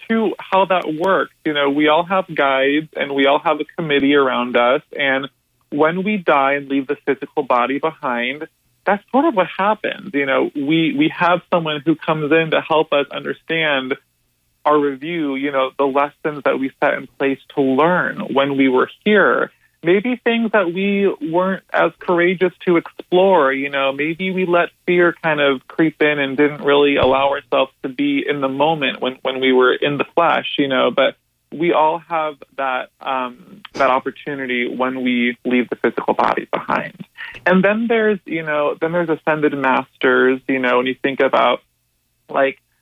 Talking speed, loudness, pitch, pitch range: 185 wpm, -17 LUFS, 150 Hz, 135-175 Hz